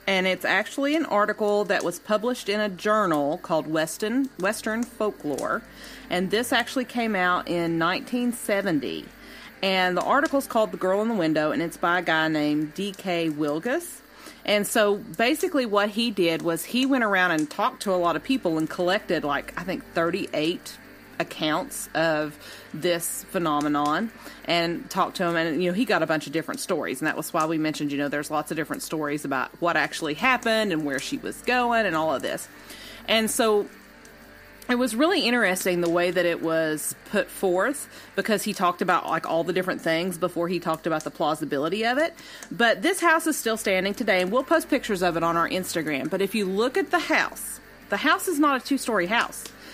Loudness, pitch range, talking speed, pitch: -24 LUFS, 165-230 Hz, 200 wpm, 190 Hz